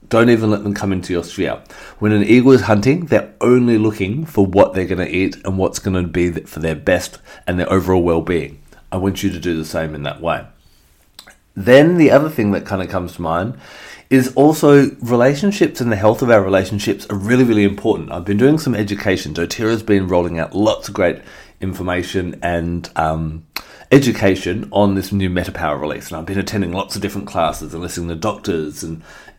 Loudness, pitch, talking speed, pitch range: -16 LUFS, 95 Hz, 210 wpm, 85-110 Hz